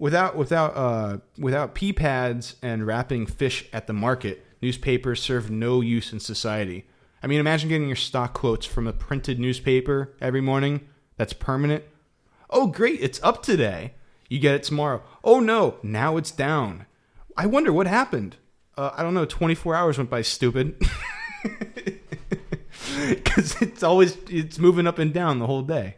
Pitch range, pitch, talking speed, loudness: 120-160 Hz, 135 Hz, 165 wpm, -24 LUFS